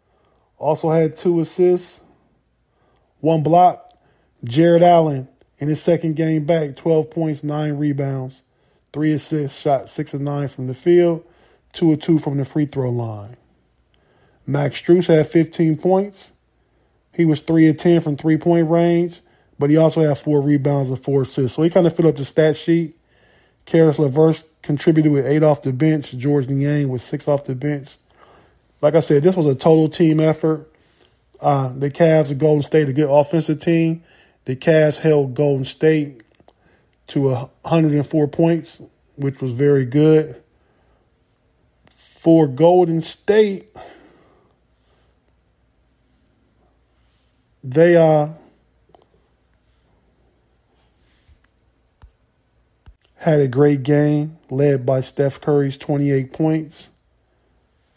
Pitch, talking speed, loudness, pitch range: 150 Hz, 130 wpm, -17 LUFS, 140-165 Hz